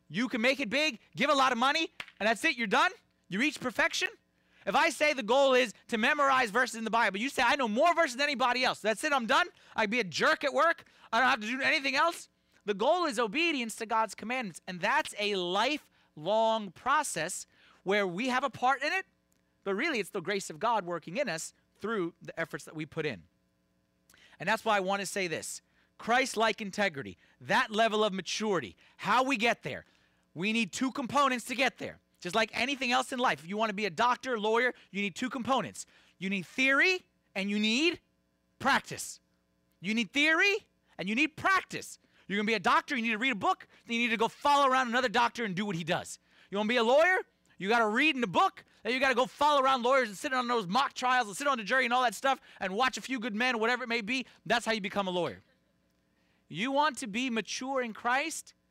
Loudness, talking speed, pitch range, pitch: -29 LUFS, 235 wpm, 205-270 Hz, 240 Hz